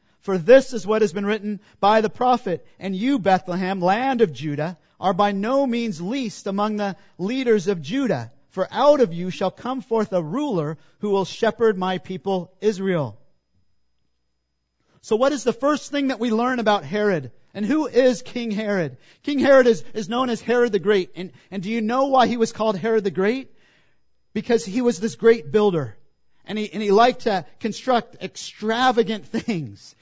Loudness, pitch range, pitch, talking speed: -21 LUFS, 185-235 Hz, 210 Hz, 185 wpm